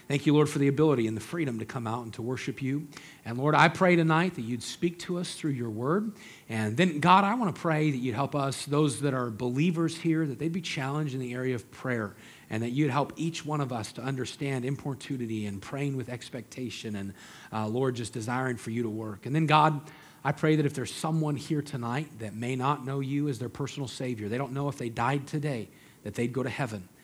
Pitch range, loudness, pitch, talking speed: 120-150 Hz, -29 LUFS, 135 Hz, 245 wpm